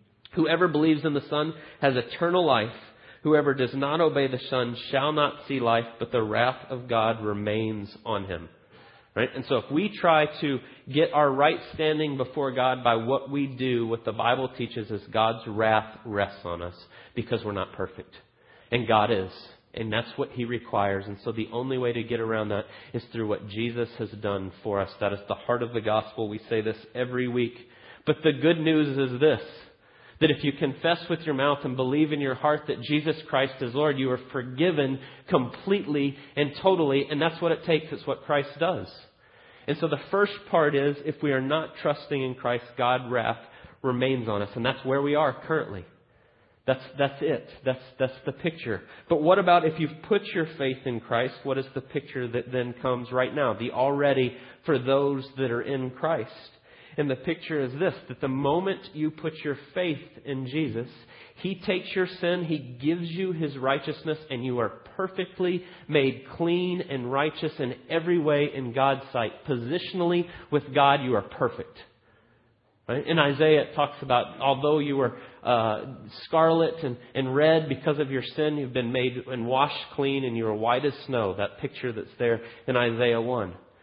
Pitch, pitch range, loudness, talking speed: 135 Hz, 120-155 Hz, -27 LUFS, 195 wpm